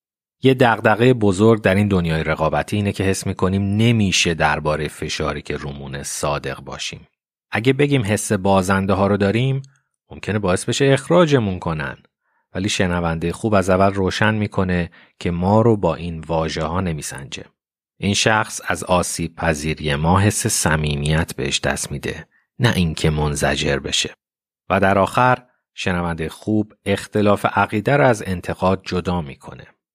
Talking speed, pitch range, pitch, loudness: 145 wpm, 80-105 Hz, 95 Hz, -19 LUFS